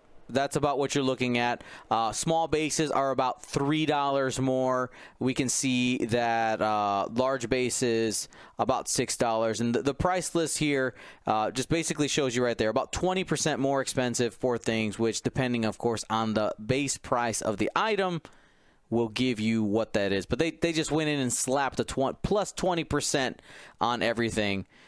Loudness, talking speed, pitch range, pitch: -28 LUFS, 180 wpm, 115-150 Hz, 130 Hz